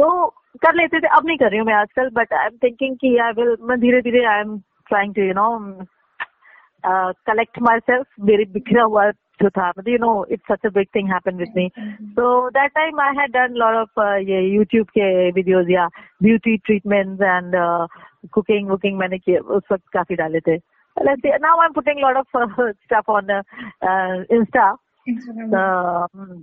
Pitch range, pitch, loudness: 190-245 Hz, 215 Hz, -18 LUFS